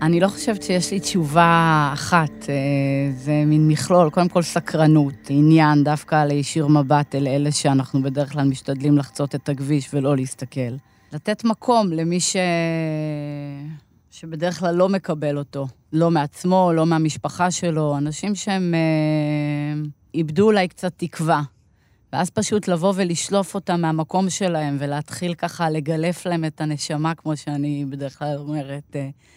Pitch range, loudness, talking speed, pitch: 145-175 Hz, -20 LUFS, 135 wpm, 155 Hz